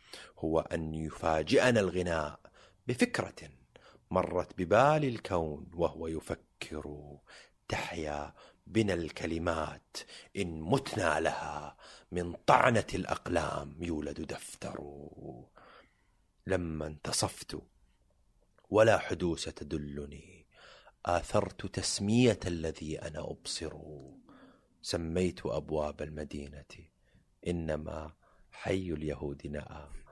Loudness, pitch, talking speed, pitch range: -33 LUFS, 80 Hz, 75 wpm, 75-90 Hz